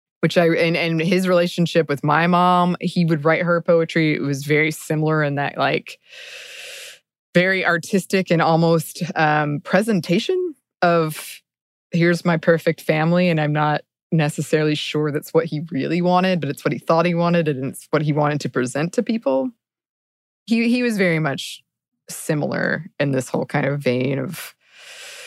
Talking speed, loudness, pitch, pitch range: 170 wpm, -19 LUFS, 165 Hz, 150-180 Hz